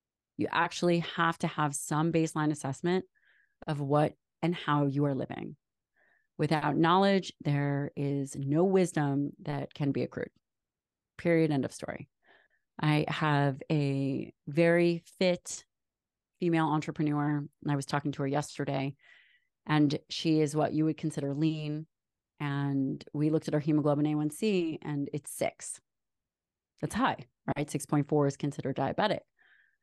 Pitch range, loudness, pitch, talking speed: 145-165 Hz, -31 LUFS, 150 Hz, 135 wpm